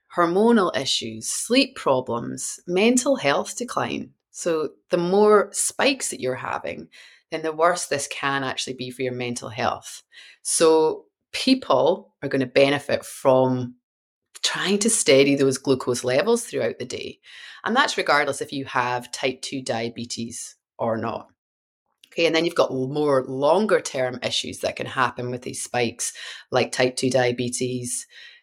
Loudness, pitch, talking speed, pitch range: -22 LUFS, 135 Hz, 150 wpm, 125-175 Hz